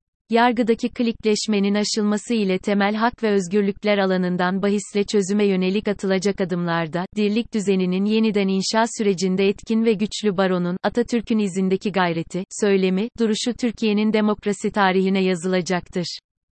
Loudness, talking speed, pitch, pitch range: -21 LUFS, 115 wpm, 205 Hz, 190-215 Hz